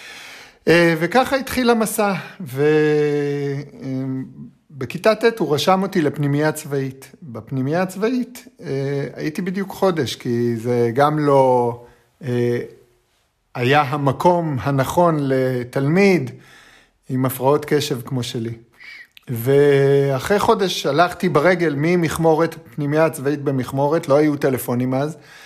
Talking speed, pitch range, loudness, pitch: 95 wpm, 130-170 Hz, -19 LUFS, 145 Hz